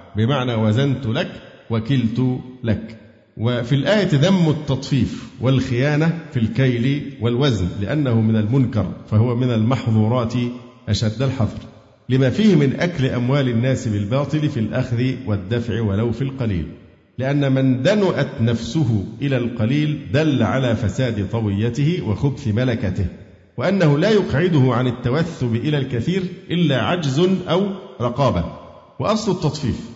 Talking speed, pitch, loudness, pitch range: 120 wpm, 125 Hz, -20 LUFS, 110-145 Hz